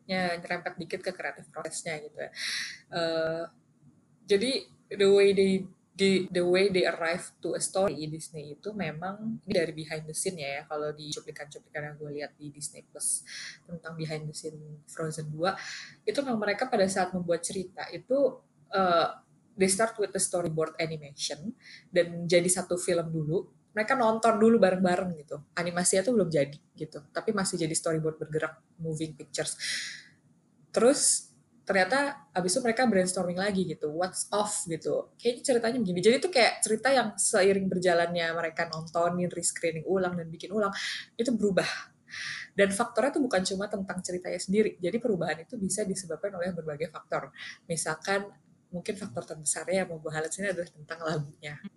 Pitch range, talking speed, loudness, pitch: 160-200 Hz, 165 wpm, -29 LUFS, 180 Hz